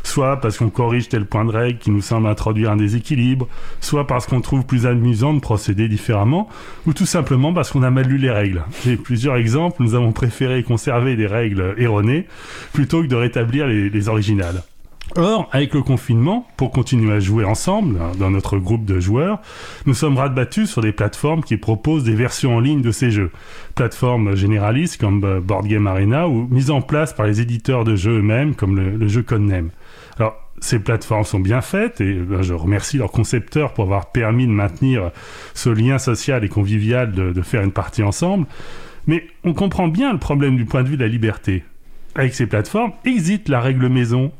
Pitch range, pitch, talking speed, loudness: 105-135 Hz, 120 Hz, 200 wpm, -18 LUFS